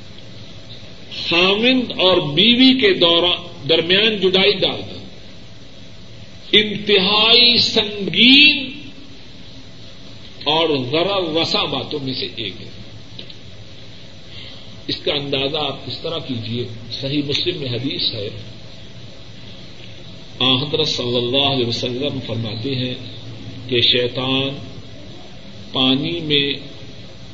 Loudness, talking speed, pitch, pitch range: -16 LUFS, 90 wpm, 140 Hz, 120-180 Hz